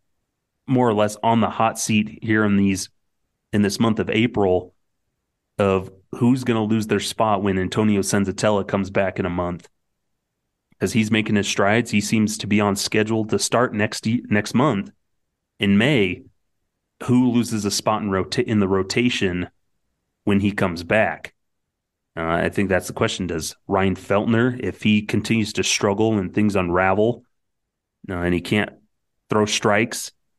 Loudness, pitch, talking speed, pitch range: -21 LUFS, 105 Hz, 165 wpm, 95-110 Hz